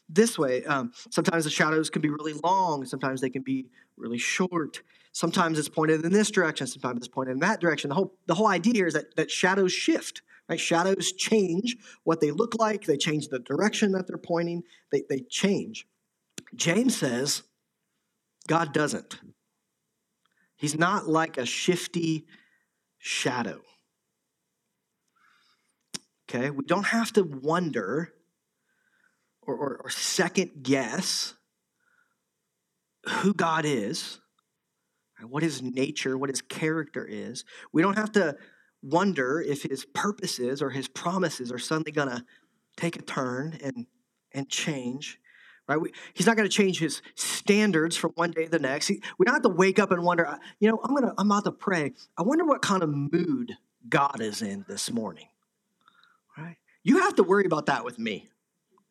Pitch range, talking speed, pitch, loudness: 150-210 Hz, 160 wpm, 170 Hz, -27 LUFS